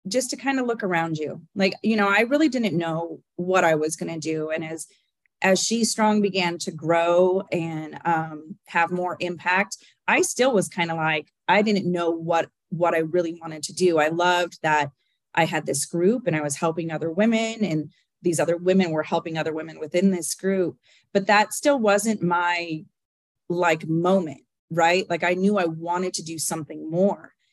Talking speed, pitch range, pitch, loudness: 195 wpm, 165-195 Hz, 175 Hz, -23 LUFS